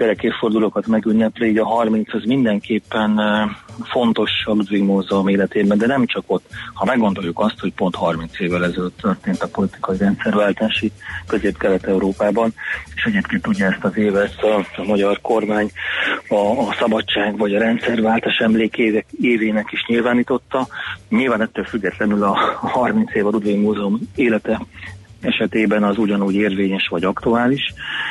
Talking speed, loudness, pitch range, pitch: 140 wpm, -18 LUFS, 100-115 Hz, 105 Hz